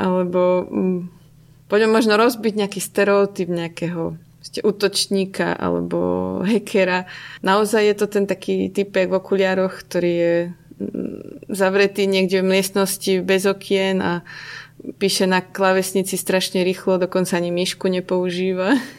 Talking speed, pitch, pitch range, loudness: 115 wpm, 190 Hz, 175-195 Hz, -19 LUFS